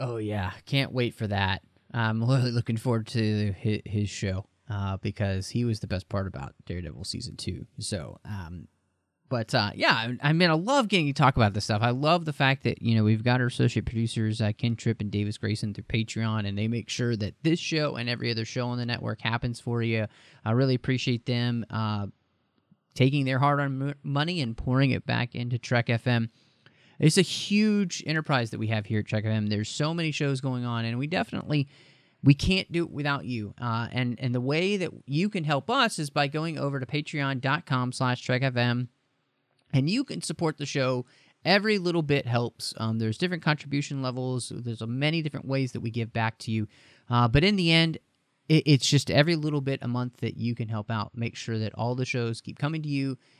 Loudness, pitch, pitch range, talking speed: -27 LUFS, 125 Hz, 110-145 Hz, 210 wpm